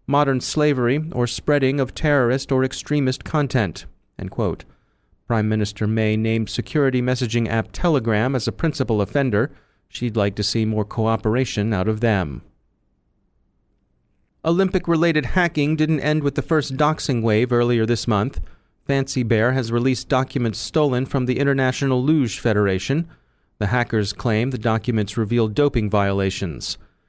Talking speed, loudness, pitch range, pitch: 140 wpm, -21 LUFS, 110-140 Hz, 120 Hz